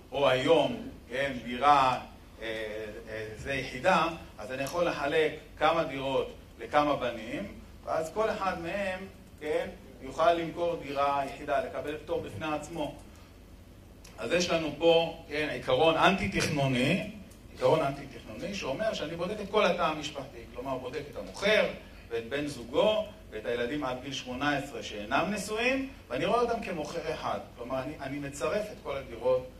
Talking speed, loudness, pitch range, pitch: 145 wpm, -30 LUFS, 130-175 Hz, 150 Hz